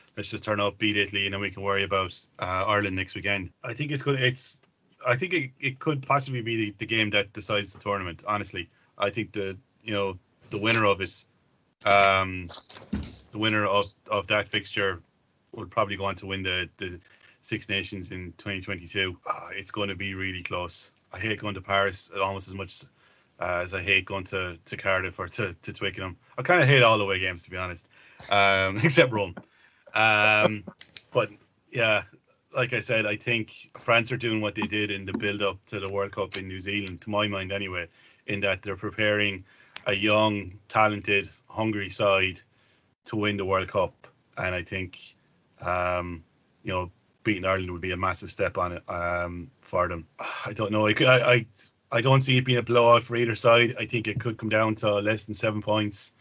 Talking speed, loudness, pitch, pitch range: 205 wpm, -26 LUFS, 100 Hz, 95-110 Hz